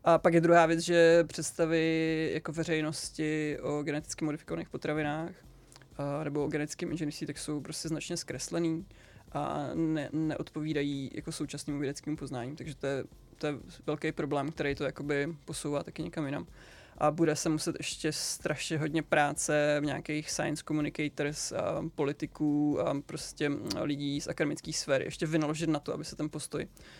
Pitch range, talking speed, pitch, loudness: 145-160 Hz, 160 wpm, 155 Hz, -32 LUFS